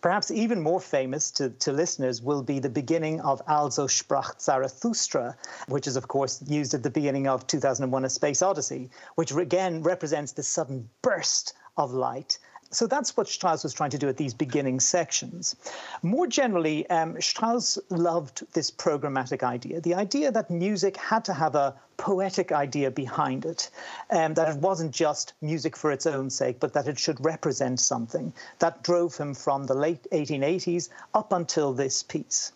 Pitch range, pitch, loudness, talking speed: 140-175 Hz, 155 Hz, -27 LUFS, 175 wpm